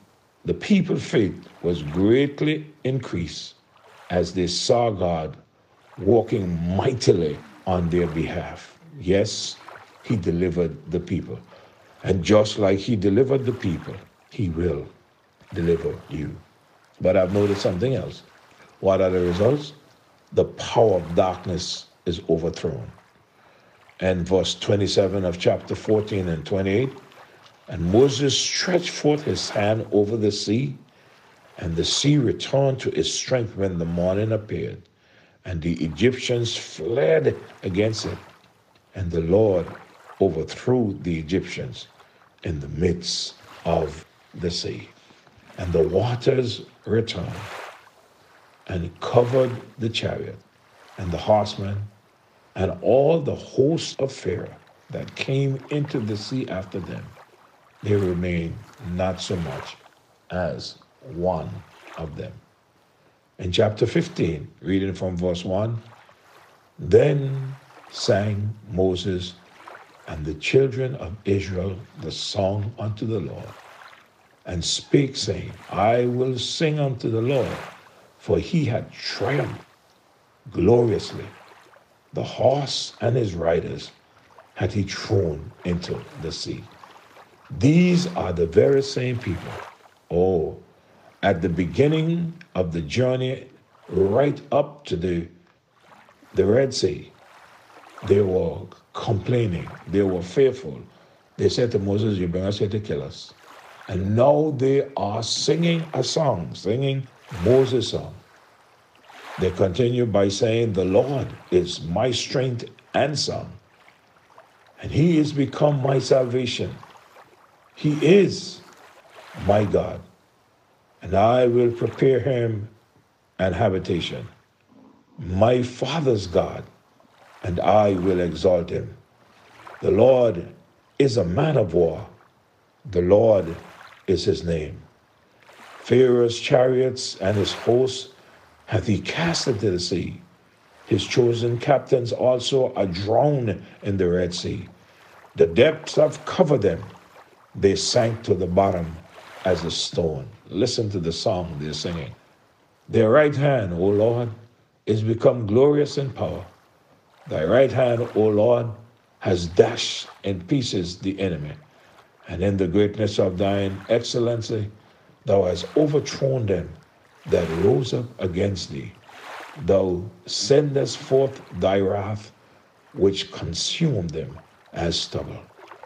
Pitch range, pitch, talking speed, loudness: 95-130 Hz, 110 Hz, 120 wpm, -23 LUFS